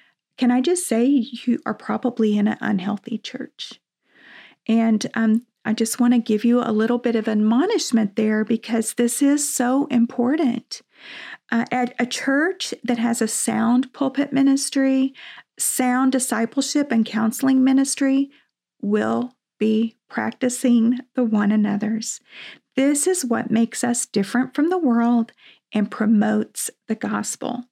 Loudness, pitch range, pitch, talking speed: -21 LUFS, 225-265 Hz, 240 Hz, 140 wpm